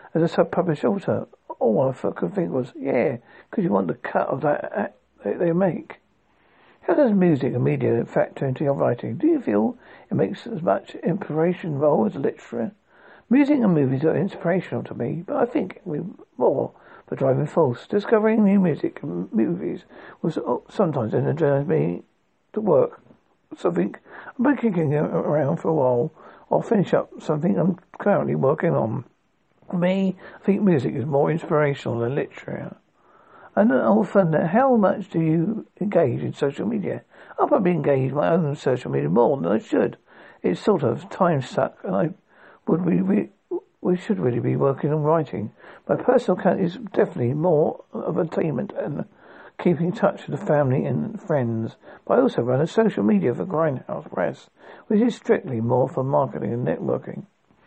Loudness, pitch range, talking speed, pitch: -23 LUFS, 145-205 Hz, 180 wpm, 170 Hz